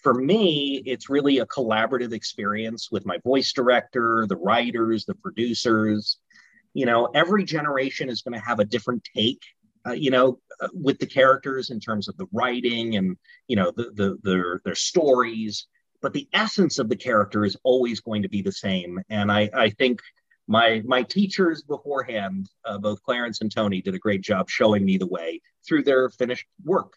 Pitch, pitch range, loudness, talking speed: 120 Hz, 105-135 Hz, -23 LUFS, 190 wpm